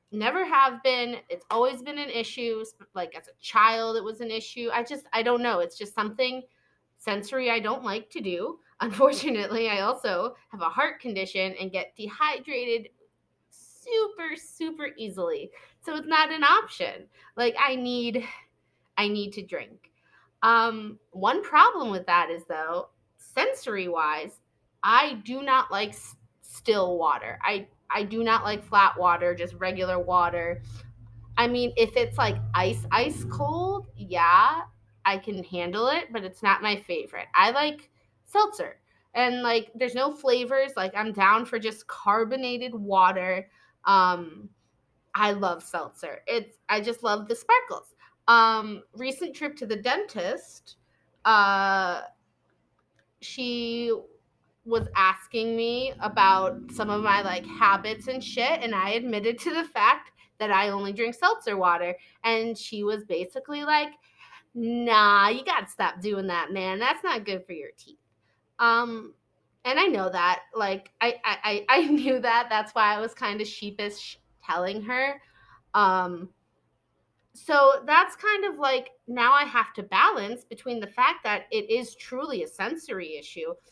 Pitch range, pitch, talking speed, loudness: 195-265 Hz, 225 Hz, 155 wpm, -25 LUFS